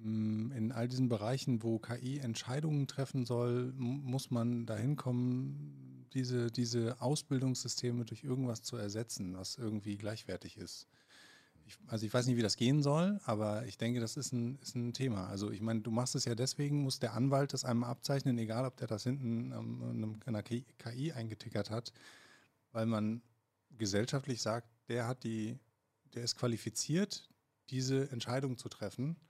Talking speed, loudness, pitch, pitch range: 165 wpm, -37 LUFS, 120 Hz, 110-130 Hz